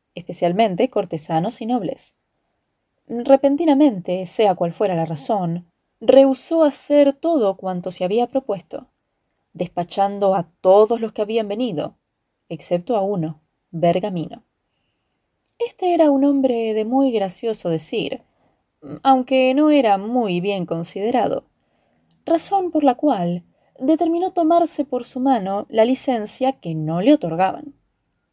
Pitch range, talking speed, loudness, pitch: 180-270 Hz, 120 wpm, -19 LUFS, 225 Hz